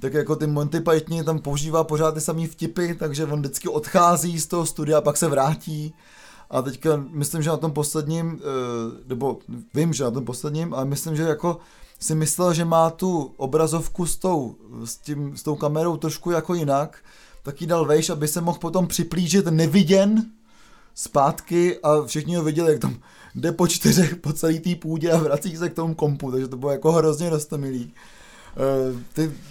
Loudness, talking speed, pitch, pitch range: -22 LUFS, 190 wpm, 160 Hz, 150-170 Hz